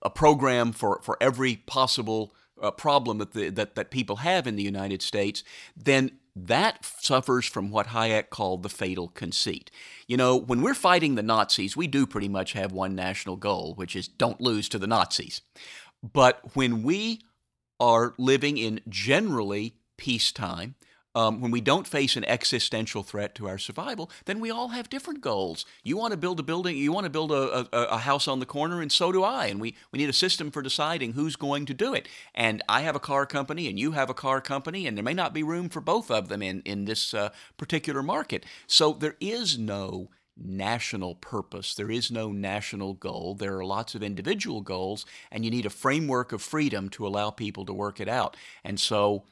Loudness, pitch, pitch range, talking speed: -27 LUFS, 120 Hz, 105-145 Hz, 210 wpm